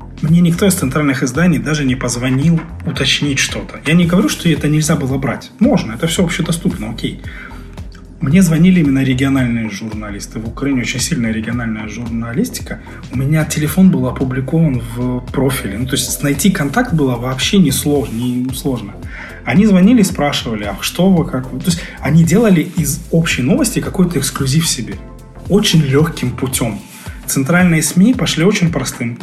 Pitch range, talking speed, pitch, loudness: 125-165 Hz, 160 wpm, 140 Hz, -14 LUFS